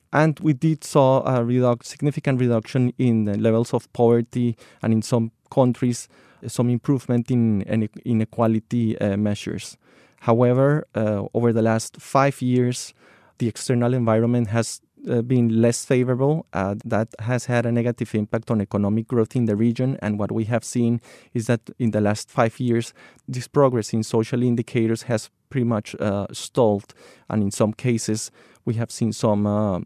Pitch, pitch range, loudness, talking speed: 120 Hz, 110-125 Hz, -22 LUFS, 165 wpm